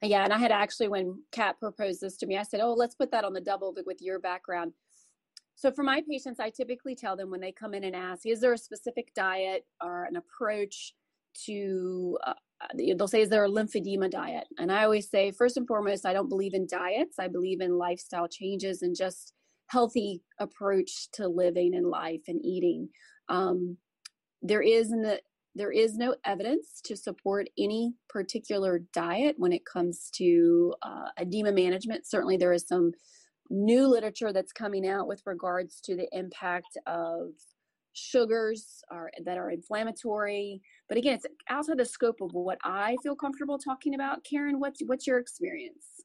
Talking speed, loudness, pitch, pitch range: 180 wpm, -30 LUFS, 205 Hz, 185-245 Hz